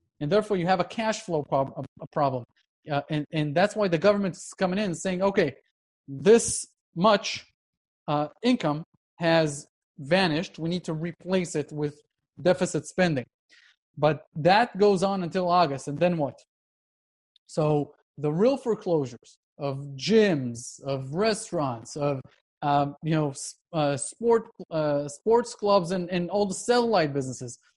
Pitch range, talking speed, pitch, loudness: 145-190 Hz, 145 wpm, 165 Hz, -26 LUFS